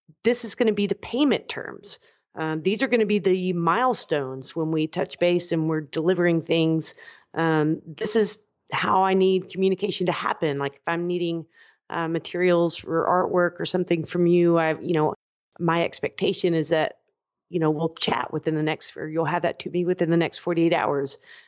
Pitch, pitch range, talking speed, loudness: 170 Hz, 160-185 Hz, 195 wpm, -24 LUFS